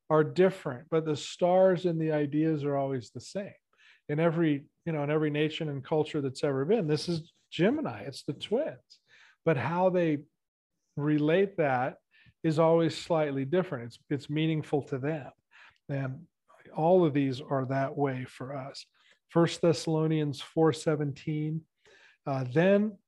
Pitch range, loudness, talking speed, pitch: 145-165 Hz, -29 LUFS, 155 wpm, 155 Hz